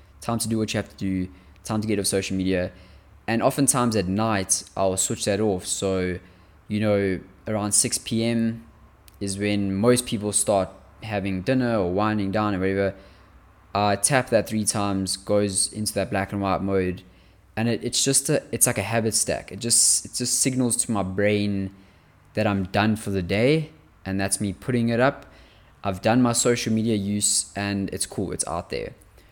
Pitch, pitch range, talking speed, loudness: 100 Hz, 95-115 Hz, 190 wpm, -23 LUFS